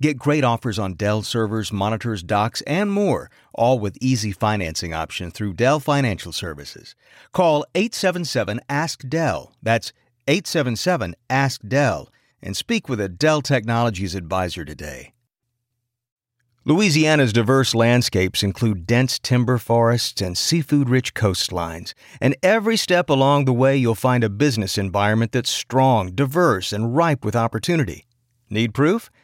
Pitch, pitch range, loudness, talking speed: 120 Hz, 105-140 Hz, -20 LUFS, 135 wpm